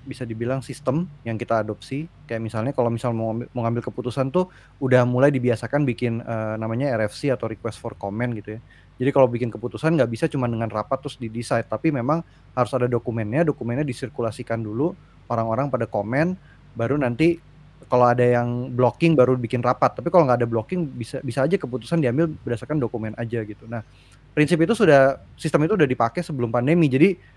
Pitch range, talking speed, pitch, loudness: 115-145 Hz, 180 wpm, 125 Hz, -23 LUFS